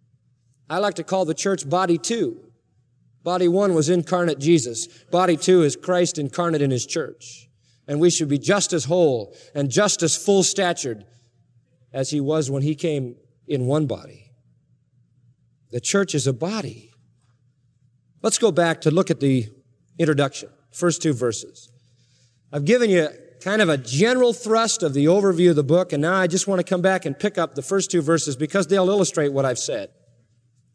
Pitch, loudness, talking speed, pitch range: 155 Hz, -21 LUFS, 180 wpm, 125-180 Hz